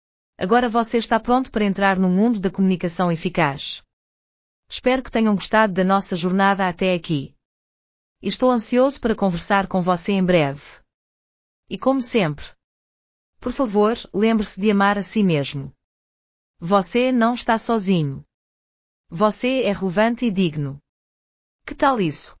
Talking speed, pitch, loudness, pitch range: 140 wpm, 195 Hz, -20 LUFS, 145-225 Hz